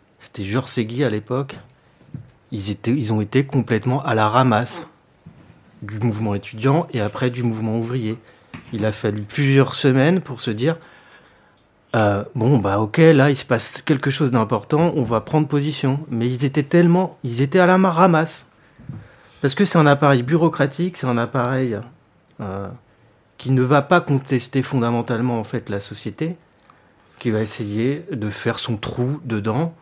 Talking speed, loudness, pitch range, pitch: 165 wpm, -19 LUFS, 110-145 Hz, 125 Hz